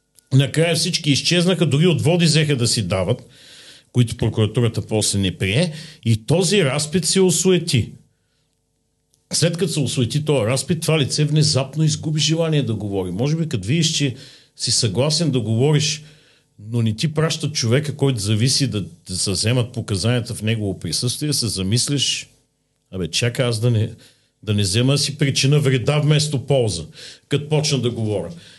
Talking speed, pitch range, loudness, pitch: 155 wpm, 115-150 Hz, -19 LUFS, 135 Hz